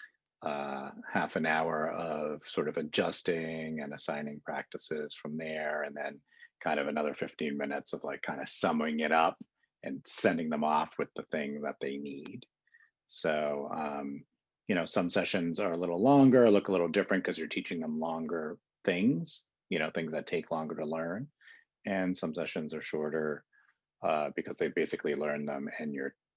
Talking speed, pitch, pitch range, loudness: 180 wpm, 75 Hz, 75-85 Hz, -33 LUFS